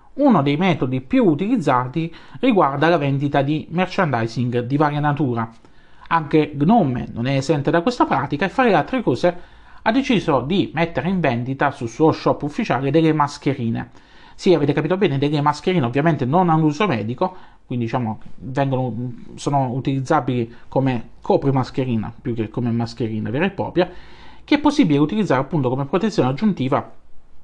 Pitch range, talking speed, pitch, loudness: 125-175 Hz, 155 wpm, 145 Hz, -20 LUFS